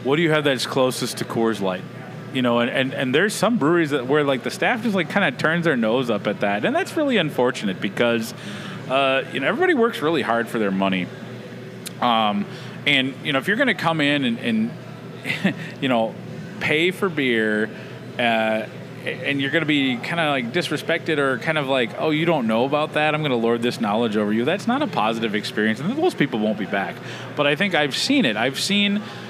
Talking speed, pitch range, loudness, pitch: 220 wpm, 120-175 Hz, -21 LUFS, 145 Hz